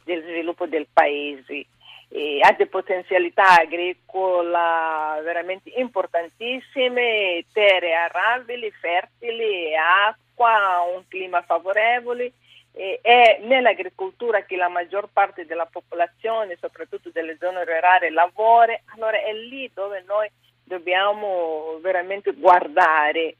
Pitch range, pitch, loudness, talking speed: 170-230 Hz, 185 Hz, -20 LUFS, 105 wpm